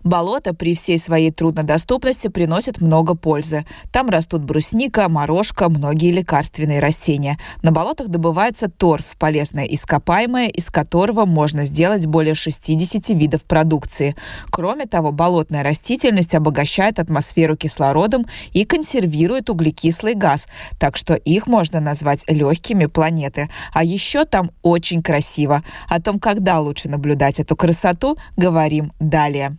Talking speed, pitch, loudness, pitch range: 125 wpm, 165 Hz, -17 LUFS, 150-185 Hz